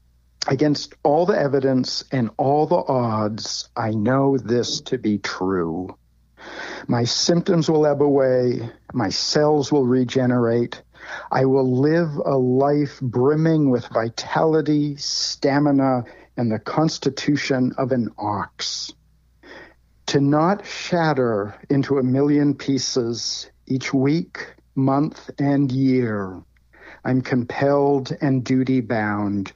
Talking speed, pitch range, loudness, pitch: 110 wpm, 120-145 Hz, -21 LUFS, 130 Hz